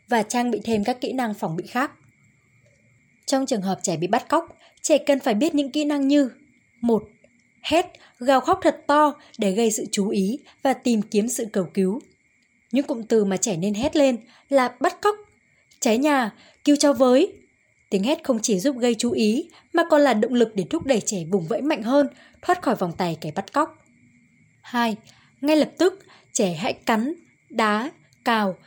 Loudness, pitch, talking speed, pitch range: -22 LUFS, 255 Hz, 200 wpm, 220-295 Hz